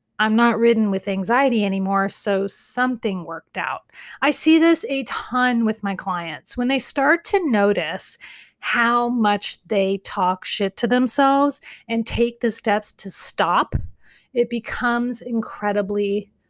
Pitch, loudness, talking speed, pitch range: 230 Hz, -20 LUFS, 140 wpm, 200-250 Hz